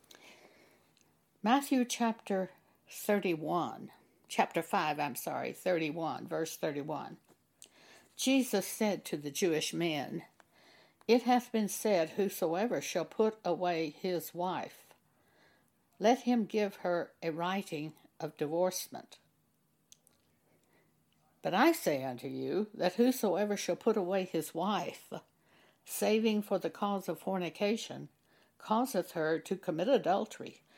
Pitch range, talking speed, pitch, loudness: 165-215 Hz, 110 wpm, 185 Hz, -33 LUFS